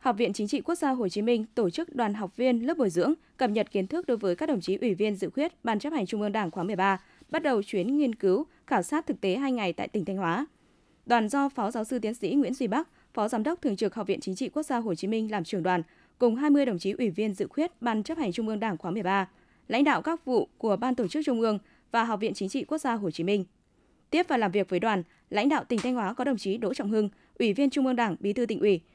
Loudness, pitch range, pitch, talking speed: -28 LUFS, 200-275 Hz, 230 Hz, 295 wpm